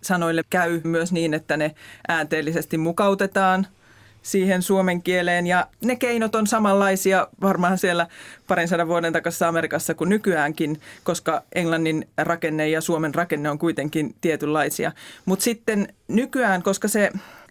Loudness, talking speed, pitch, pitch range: -22 LUFS, 135 wpm, 170 Hz, 160-195 Hz